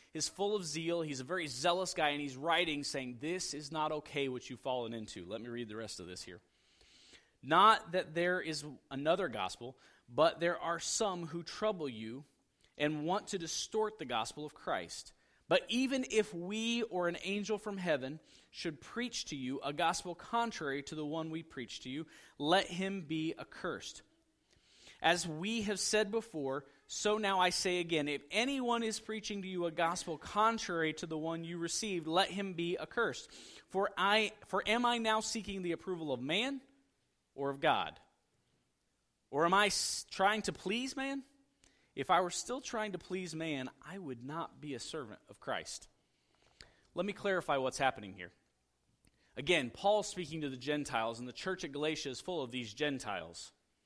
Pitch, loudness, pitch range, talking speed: 170 Hz, -36 LUFS, 145-200 Hz, 185 wpm